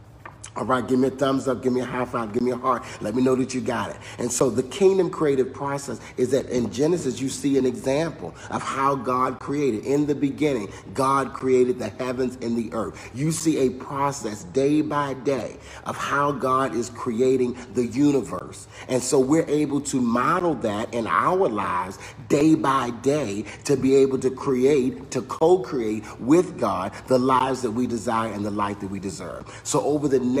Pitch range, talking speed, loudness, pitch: 115-140 Hz, 200 wpm, -23 LUFS, 130 Hz